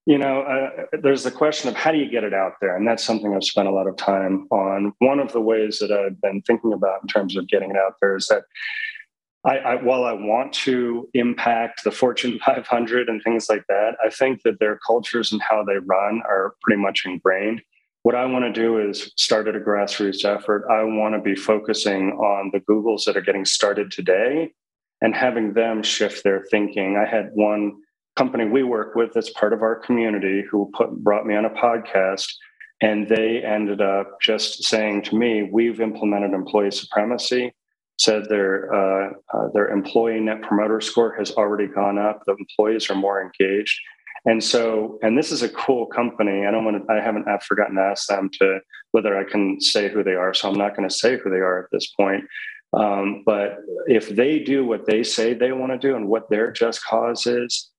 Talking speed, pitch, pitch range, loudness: 215 wpm, 110 Hz, 100-115 Hz, -21 LUFS